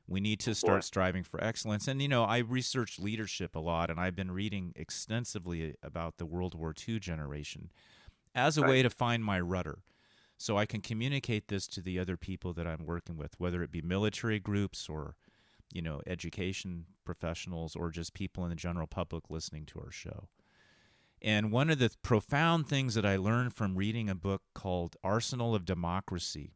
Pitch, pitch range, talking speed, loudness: 95 Hz, 85-110 Hz, 190 wpm, -34 LUFS